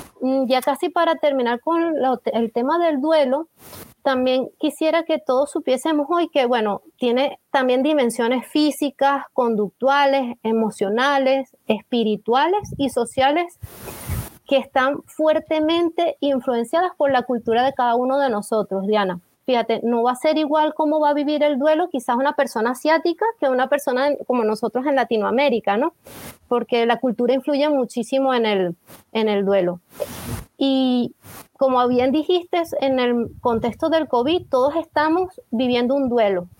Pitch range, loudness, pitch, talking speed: 240-300 Hz, -20 LUFS, 265 Hz, 145 wpm